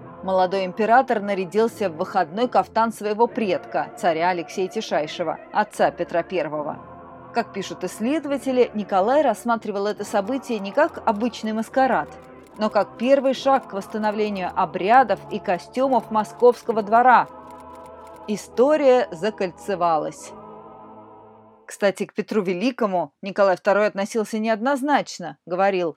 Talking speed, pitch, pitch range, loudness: 110 wpm, 210 Hz, 185-235 Hz, -22 LUFS